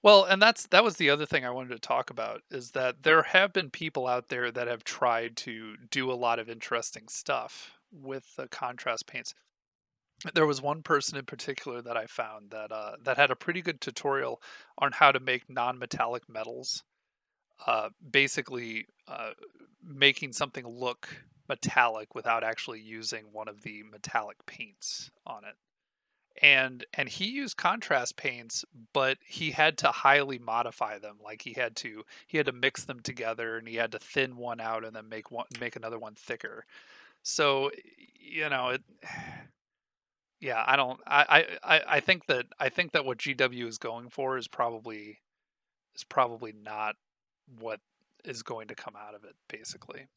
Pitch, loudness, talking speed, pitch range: 130 Hz, -28 LUFS, 175 wpm, 115-145 Hz